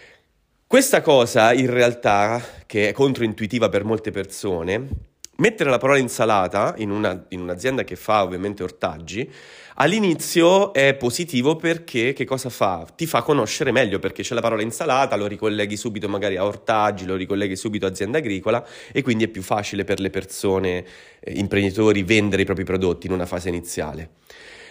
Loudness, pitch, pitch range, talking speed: -21 LUFS, 105 Hz, 95-125 Hz, 165 wpm